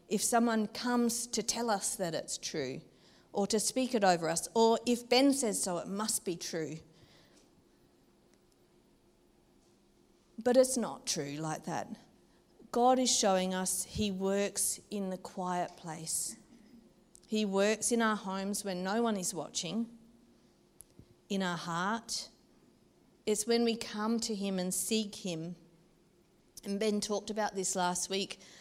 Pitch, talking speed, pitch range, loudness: 205 Hz, 145 wpm, 180-230 Hz, -33 LUFS